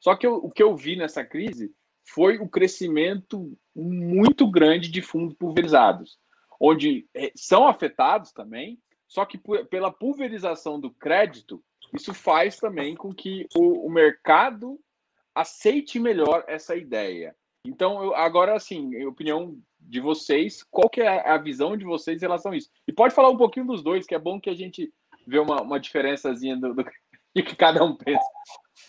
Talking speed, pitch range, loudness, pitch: 170 wpm, 160-255 Hz, -23 LUFS, 190 Hz